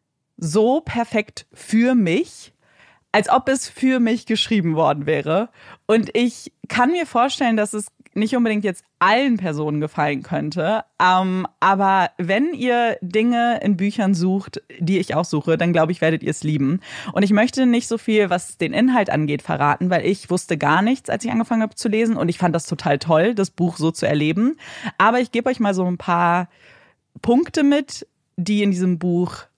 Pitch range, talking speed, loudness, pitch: 175-235 Hz, 185 wpm, -19 LUFS, 200 Hz